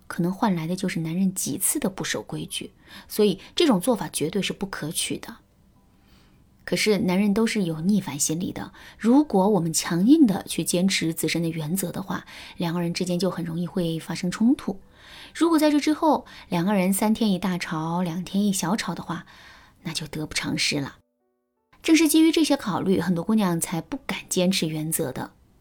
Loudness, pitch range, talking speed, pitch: -24 LUFS, 165-210 Hz, 280 characters per minute, 185 Hz